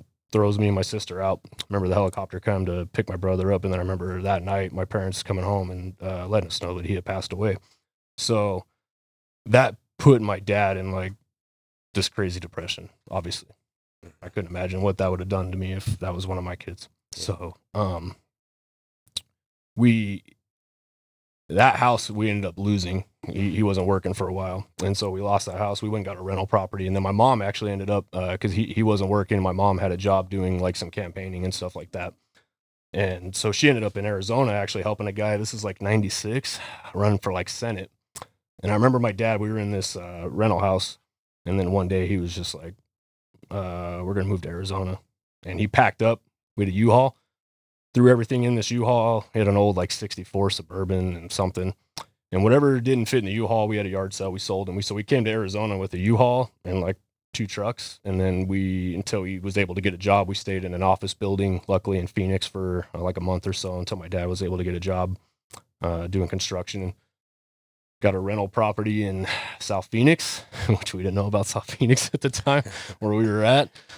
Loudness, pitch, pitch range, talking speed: -25 LUFS, 100 Hz, 95-105 Hz, 225 wpm